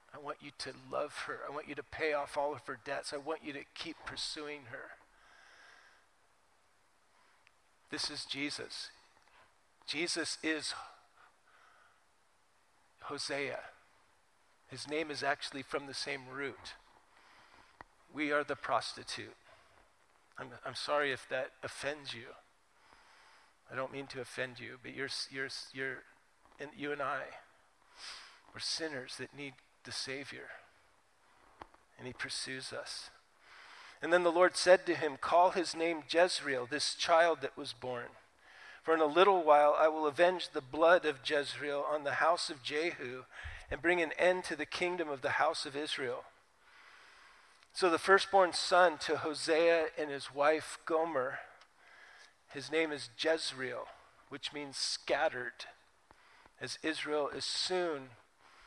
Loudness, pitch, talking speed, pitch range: -34 LUFS, 150 Hz, 140 wpm, 140-165 Hz